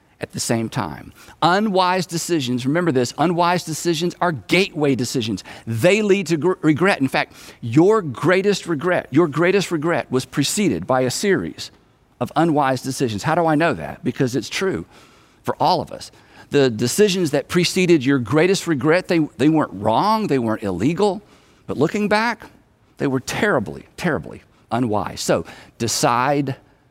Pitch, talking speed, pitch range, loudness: 155 Hz, 155 wpm, 130-180 Hz, -19 LUFS